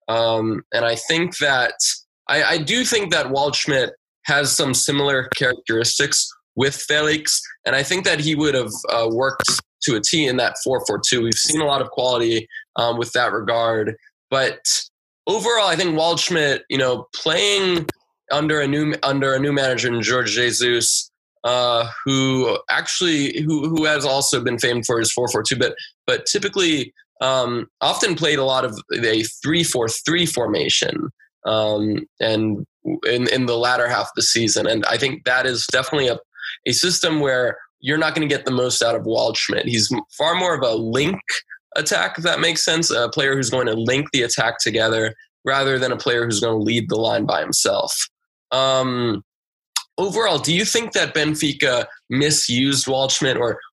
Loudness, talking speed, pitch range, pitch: -19 LUFS, 180 wpm, 120-155 Hz, 130 Hz